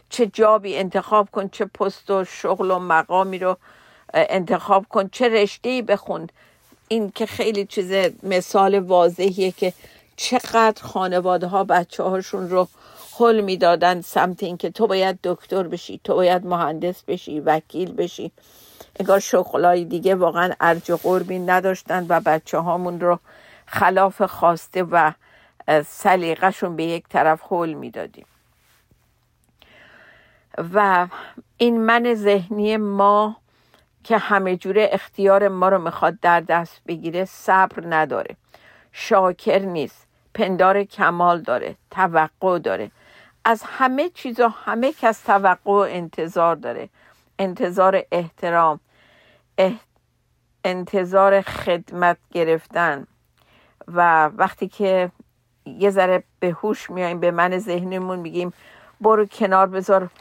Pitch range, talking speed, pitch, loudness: 175-200 Hz, 120 wpm, 190 Hz, -20 LUFS